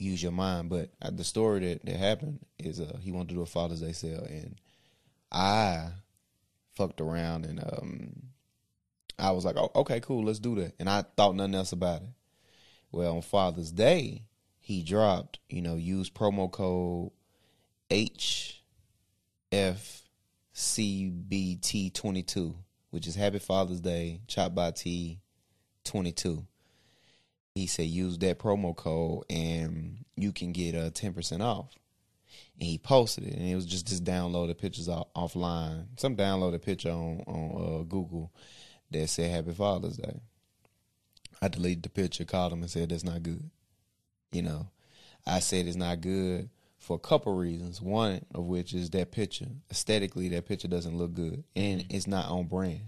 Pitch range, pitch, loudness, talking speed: 85-100 Hz, 90 Hz, -32 LUFS, 165 wpm